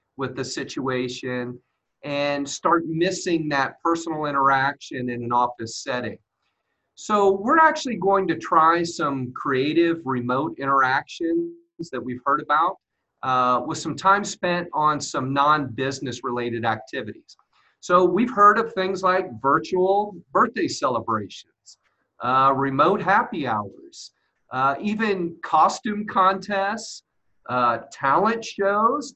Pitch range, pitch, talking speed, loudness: 130-195 Hz, 160 Hz, 120 wpm, -22 LUFS